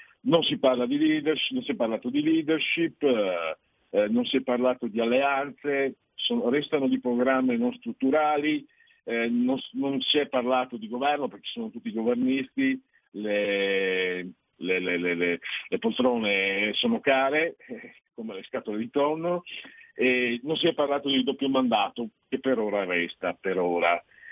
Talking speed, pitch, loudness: 150 wpm, 135 Hz, -26 LUFS